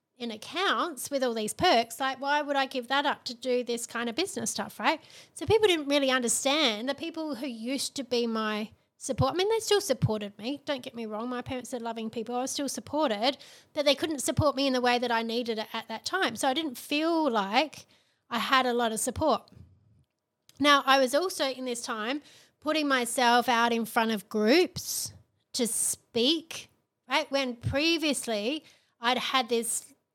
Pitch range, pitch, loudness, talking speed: 235-290 Hz, 260 Hz, -28 LUFS, 200 wpm